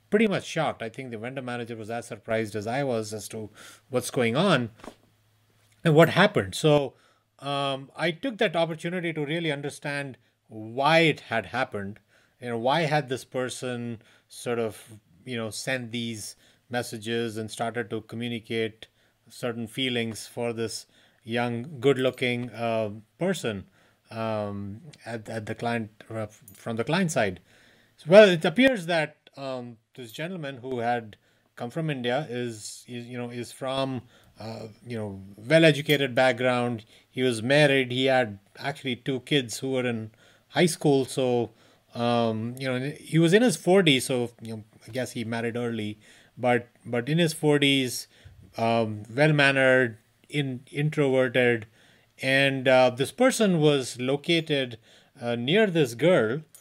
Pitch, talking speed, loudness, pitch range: 125 Hz, 155 wpm, -26 LUFS, 115-140 Hz